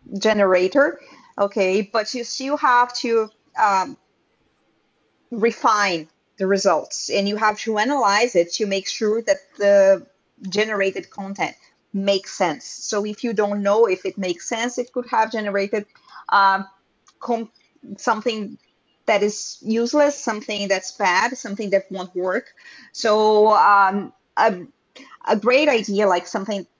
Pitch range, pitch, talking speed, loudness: 195-235 Hz, 210 Hz, 135 wpm, -20 LUFS